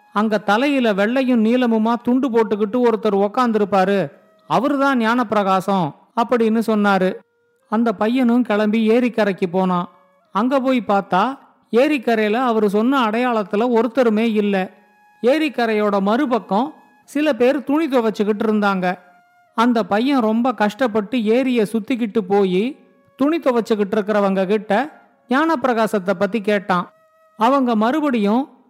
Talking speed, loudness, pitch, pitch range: 105 wpm, -18 LUFS, 225 Hz, 210-255 Hz